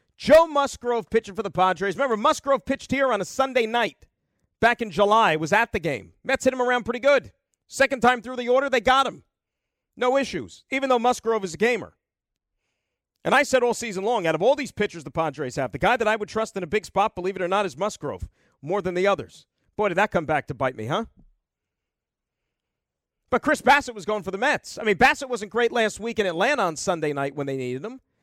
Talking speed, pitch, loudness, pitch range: 235 wpm, 220 Hz, -23 LUFS, 190-255 Hz